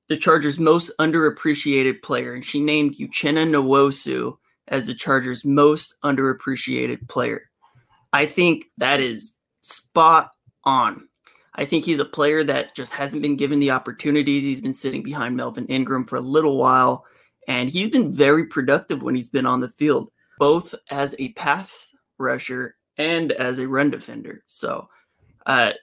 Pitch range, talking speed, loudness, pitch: 130-155 Hz, 155 wpm, -20 LUFS, 145 Hz